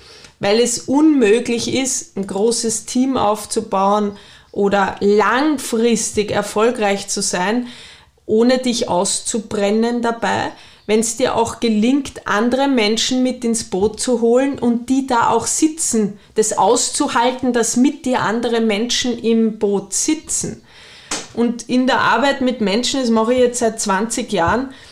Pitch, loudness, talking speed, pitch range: 230 Hz, -17 LUFS, 135 wpm, 210-250 Hz